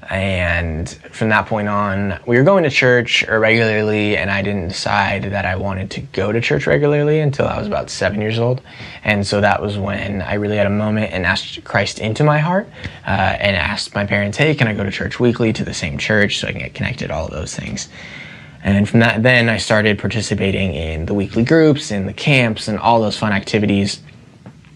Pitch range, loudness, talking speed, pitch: 100-115 Hz, -17 LUFS, 220 wpm, 105 Hz